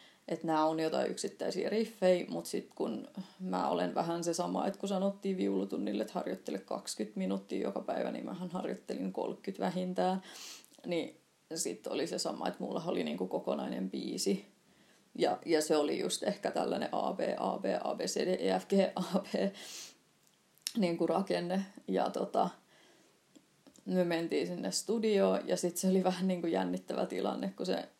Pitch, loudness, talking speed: 175 Hz, -35 LUFS, 150 wpm